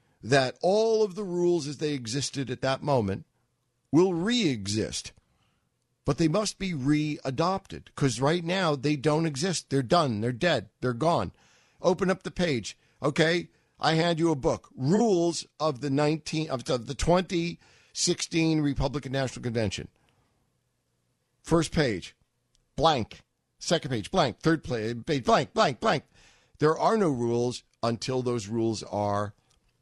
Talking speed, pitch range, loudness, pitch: 140 wpm, 125-170 Hz, -27 LUFS, 145 Hz